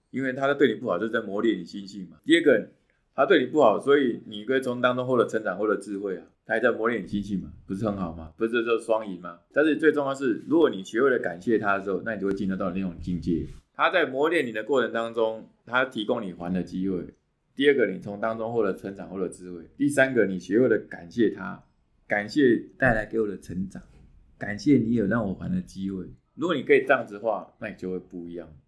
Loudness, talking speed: -25 LUFS, 360 characters per minute